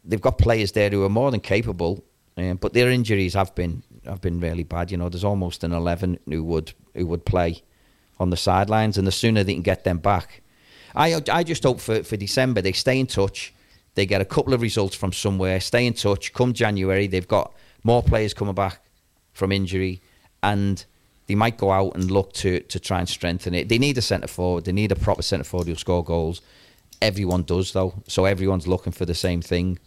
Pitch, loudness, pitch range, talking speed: 95 Hz, -23 LUFS, 90-105 Hz, 220 wpm